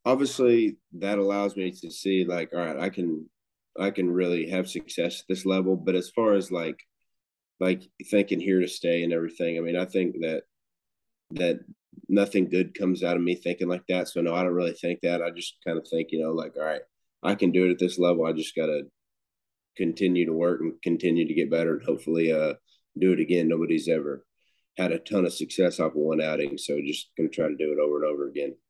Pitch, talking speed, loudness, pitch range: 90 Hz, 230 wpm, -27 LUFS, 85-95 Hz